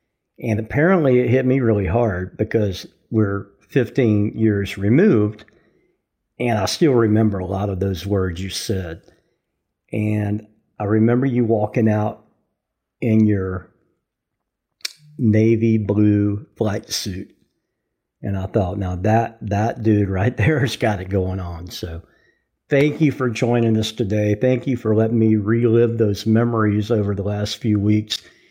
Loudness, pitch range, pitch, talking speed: -19 LUFS, 100-115 Hz, 110 Hz, 145 wpm